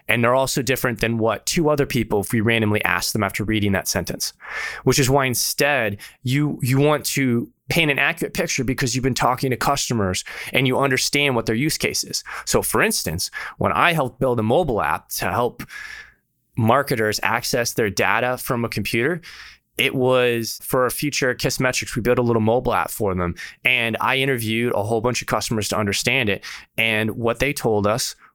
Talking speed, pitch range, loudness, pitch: 200 wpm, 110-135 Hz, -20 LUFS, 120 Hz